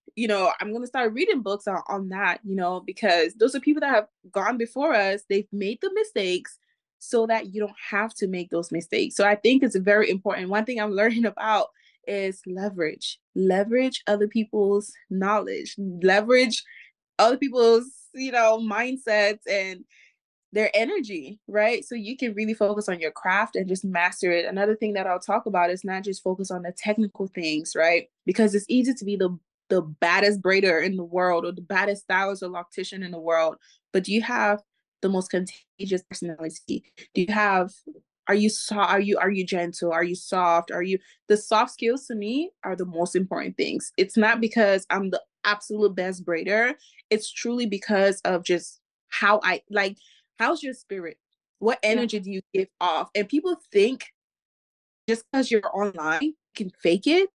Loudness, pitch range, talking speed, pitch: -24 LUFS, 185-230 Hz, 190 wpm, 205 Hz